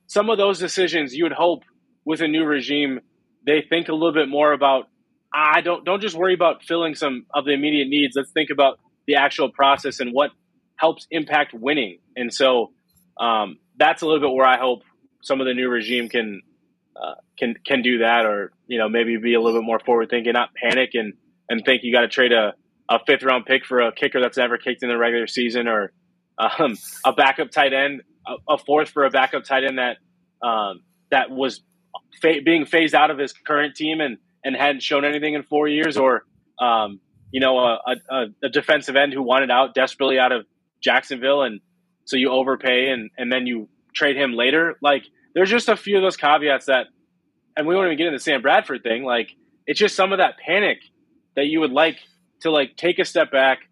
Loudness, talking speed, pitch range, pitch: -20 LUFS, 215 wpm, 125-160 Hz, 140 Hz